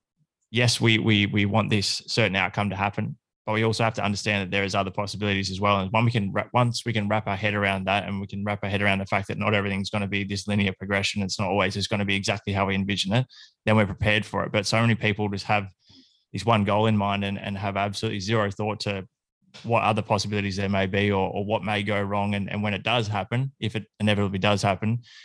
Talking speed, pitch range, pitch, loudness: 265 wpm, 100-110 Hz, 105 Hz, -25 LUFS